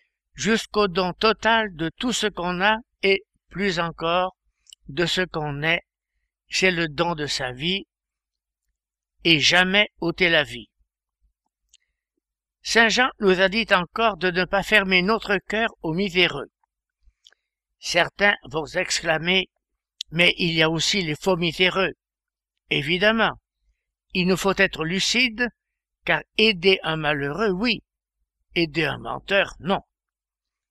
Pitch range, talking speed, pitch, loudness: 160-205 Hz, 130 wpm, 185 Hz, -21 LUFS